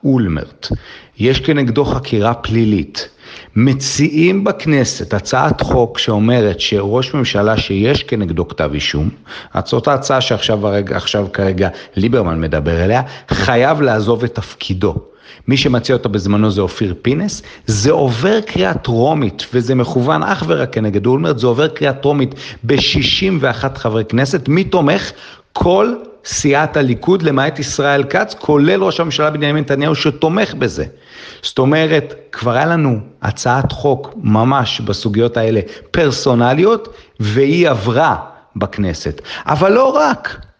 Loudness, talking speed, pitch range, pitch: -14 LUFS, 125 wpm, 110-145 Hz, 125 Hz